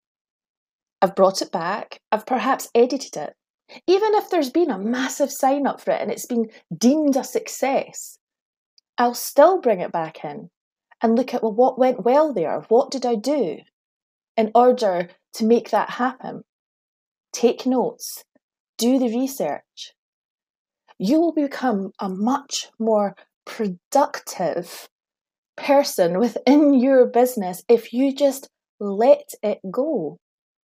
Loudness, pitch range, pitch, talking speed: -21 LUFS, 225-275 Hz, 250 Hz, 135 wpm